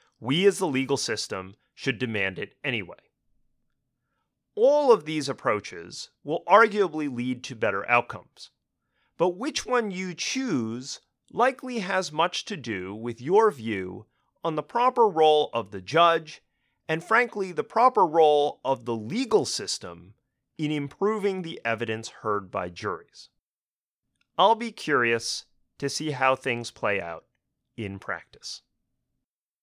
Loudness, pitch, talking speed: -25 LUFS, 150 Hz, 135 wpm